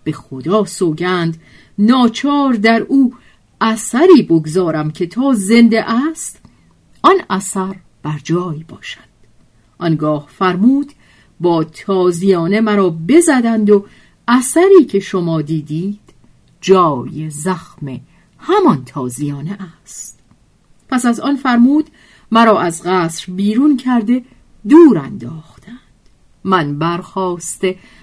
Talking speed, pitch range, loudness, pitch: 100 wpm, 165-240 Hz, -14 LUFS, 190 Hz